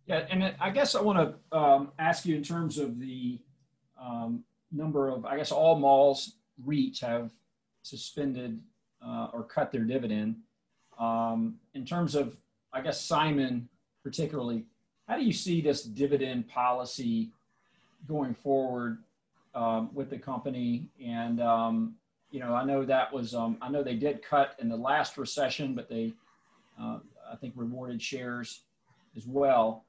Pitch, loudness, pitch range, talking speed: 135 Hz, -30 LUFS, 120-155 Hz, 155 wpm